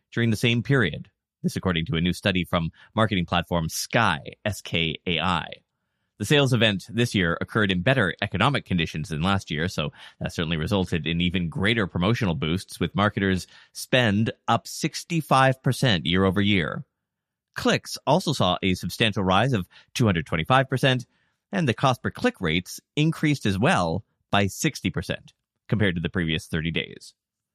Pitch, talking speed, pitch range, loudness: 100 Hz, 150 wpm, 90-120 Hz, -24 LUFS